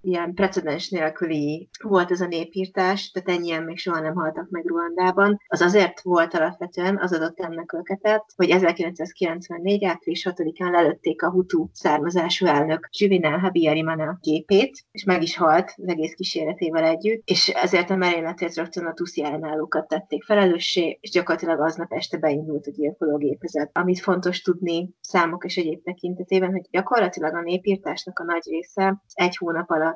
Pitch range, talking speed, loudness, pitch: 165-185 Hz, 150 wpm, -23 LUFS, 175 Hz